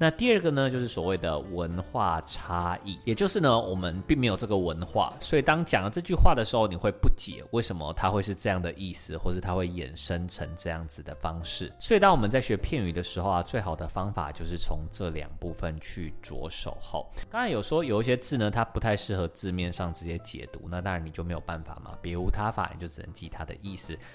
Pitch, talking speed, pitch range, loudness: 90 Hz, 350 characters per minute, 85-105 Hz, -29 LUFS